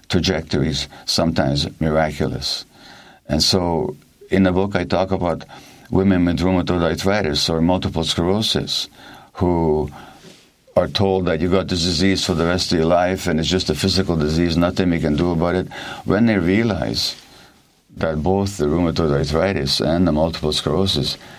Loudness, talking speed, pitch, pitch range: -19 LUFS, 155 wpm, 90 Hz, 80-95 Hz